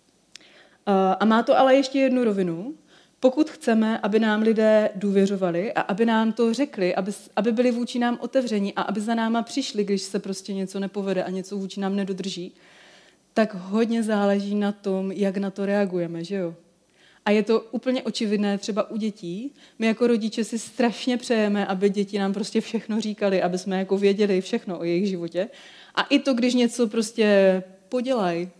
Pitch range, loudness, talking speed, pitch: 195-230 Hz, -24 LUFS, 175 wpm, 210 Hz